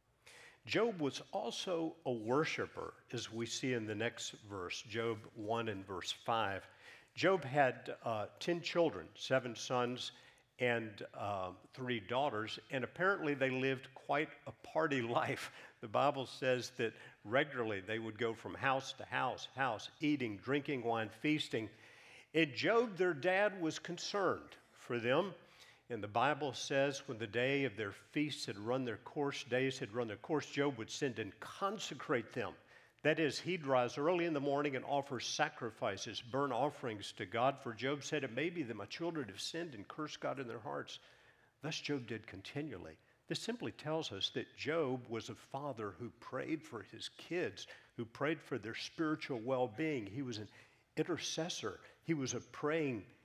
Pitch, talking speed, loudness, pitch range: 135 Hz, 170 wpm, -39 LUFS, 115-150 Hz